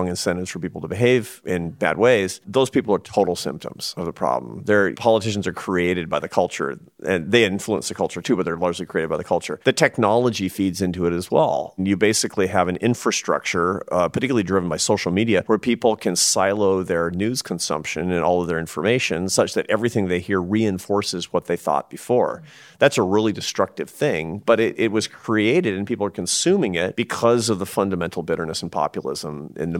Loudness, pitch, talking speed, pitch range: -21 LUFS, 95 Hz, 200 wpm, 90-110 Hz